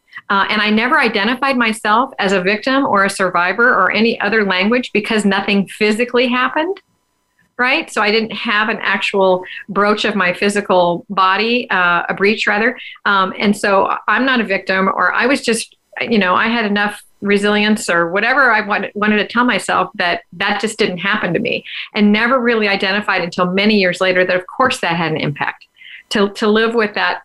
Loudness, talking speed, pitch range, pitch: -15 LUFS, 195 wpm, 195-230 Hz, 210 Hz